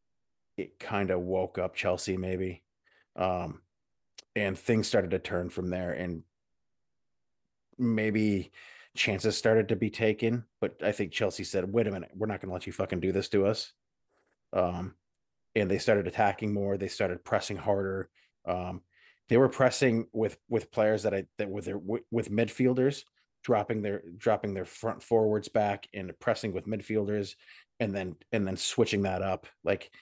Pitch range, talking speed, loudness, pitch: 90-110 Hz, 170 wpm, -30 LUFS, 100 Hz